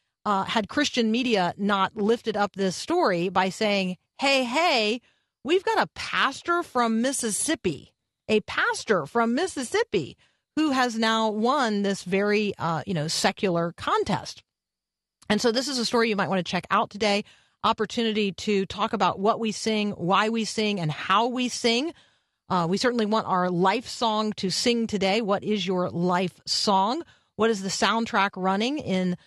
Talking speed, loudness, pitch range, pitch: 170 wpm, -25 LUFS, 190-235 Hz, 215 Hz